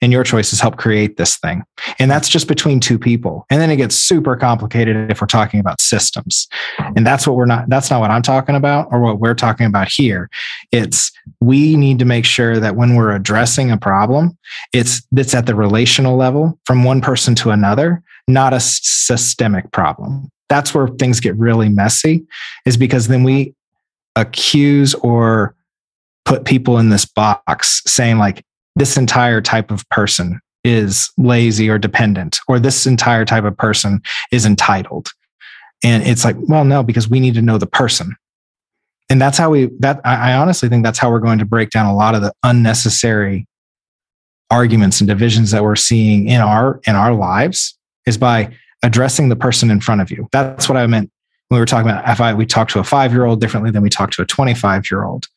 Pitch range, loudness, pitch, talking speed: 110-130 Hz, -13 LUFS, 120 Hz, 195 wpm